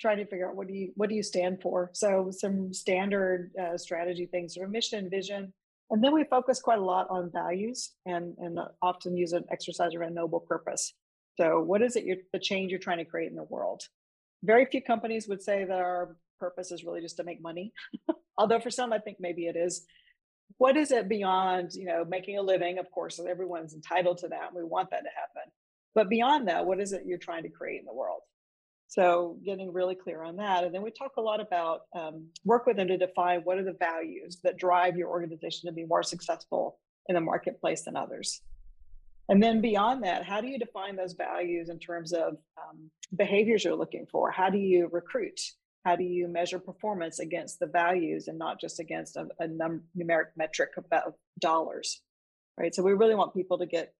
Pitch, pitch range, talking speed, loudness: 180 Hz, 175-205 Hz, 220 wpm, -30 LUFS